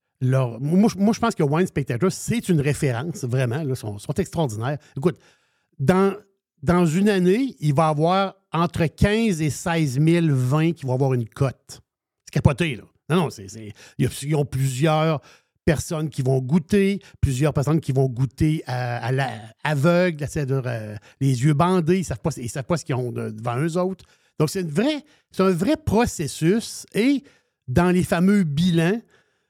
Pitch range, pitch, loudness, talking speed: 135-180 Hz, 155 Hz, -22 LUFS, 180 wpm